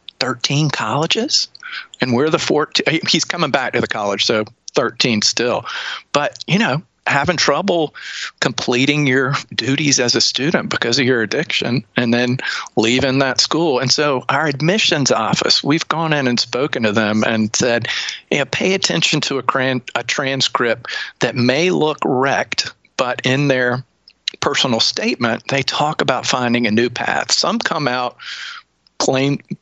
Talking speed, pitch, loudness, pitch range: 155 wpm, 135 Hz, -16 LUFS, 120-155 Hz